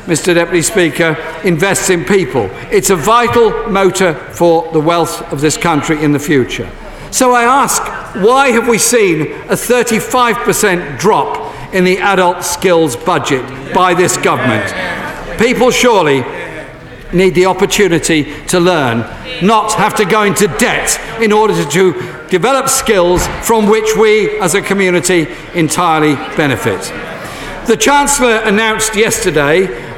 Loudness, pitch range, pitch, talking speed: -11 LUFS, 170-220 Hz, 185 Hz, 135 wpm